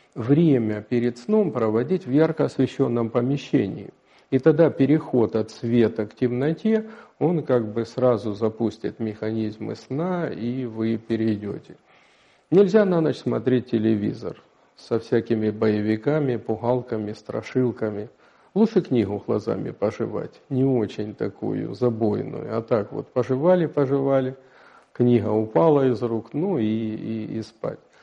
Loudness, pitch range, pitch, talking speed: -23 LUFS, 110-140 Hz, 120 Hz, 120 wpm